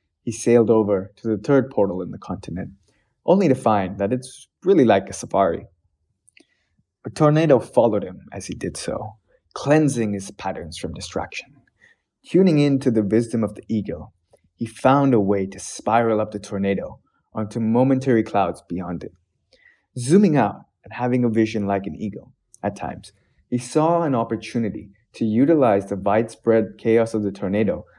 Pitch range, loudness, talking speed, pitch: 100-125 Hz, -21 LUFS, 165 wpm, 110 Hz